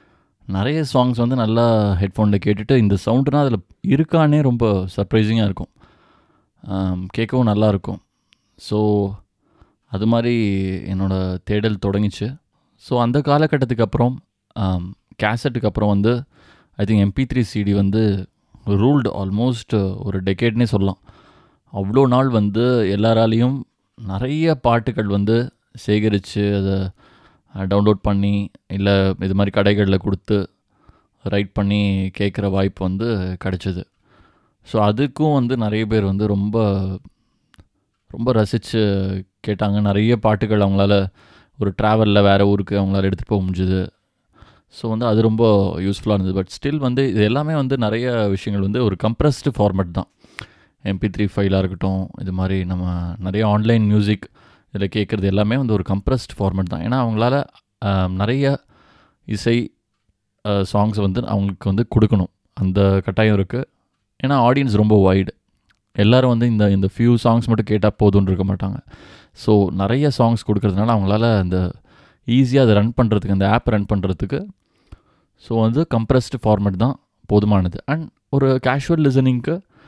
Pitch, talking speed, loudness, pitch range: 105 Hz, 130 wpm, -18 LUFS, 100-120 Hz